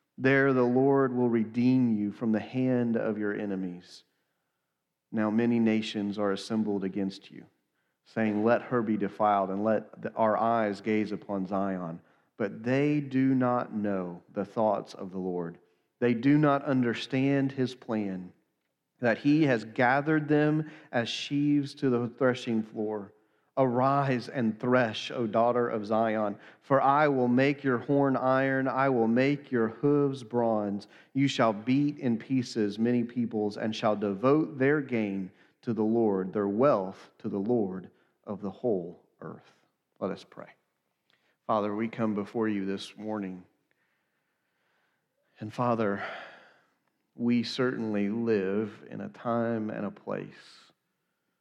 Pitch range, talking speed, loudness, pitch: 105-130 Hz, 145 wpm, -28 LUFS, 115 Hz